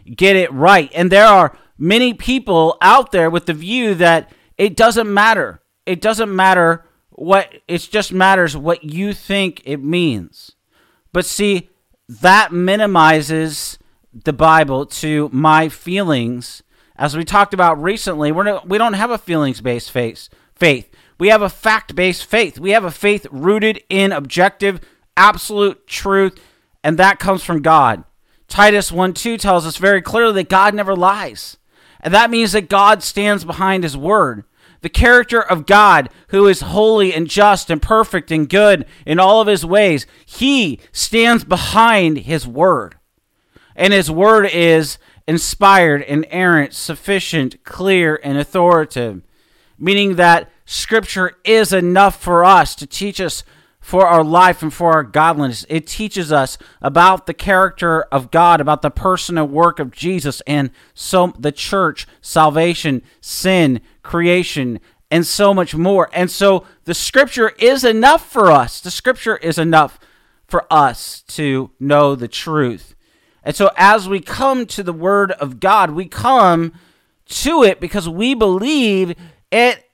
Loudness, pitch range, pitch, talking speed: -13 LUFS, 160-200 Hz, 180 Hz, 150 wpm